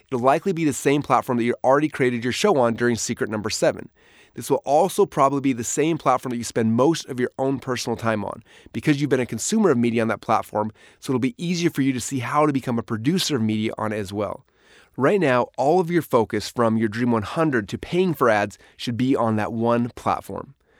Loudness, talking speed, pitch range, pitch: -22 LUFS, 240 wpm, 115-145 Hz, 125 Hz